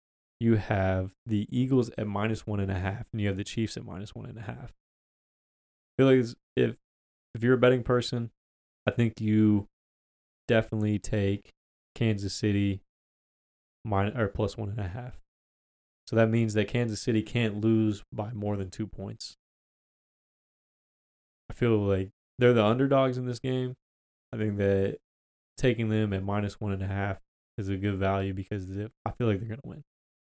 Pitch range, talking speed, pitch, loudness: 95-115 Hz, 180 wpm, 105 Hz, -29 LUFS